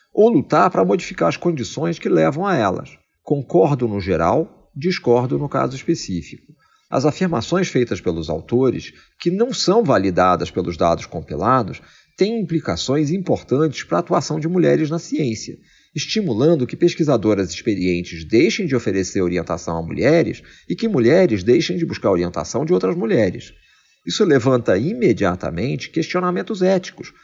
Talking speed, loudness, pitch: 140 wpm, -19 LUFS, 135 Hz